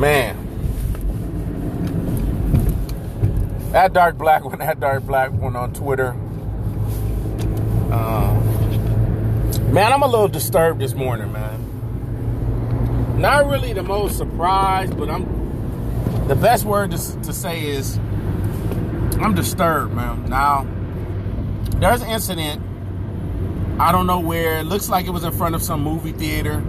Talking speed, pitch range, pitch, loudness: 125 wpm, 105-125 Hz, 110 Hz, -20 LUFS